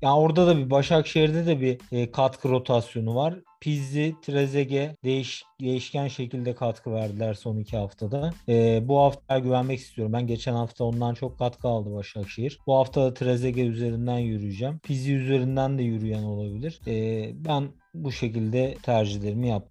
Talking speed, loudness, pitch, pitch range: 155 wpm, -26 LUFS, 130 Hz, 115-140 Hz